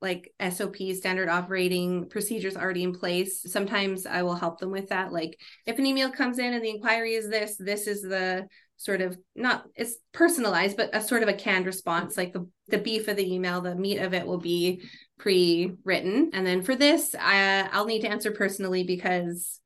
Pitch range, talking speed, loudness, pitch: 180-215 Hz, 200 wpm, -27 LUFS, 190 Hz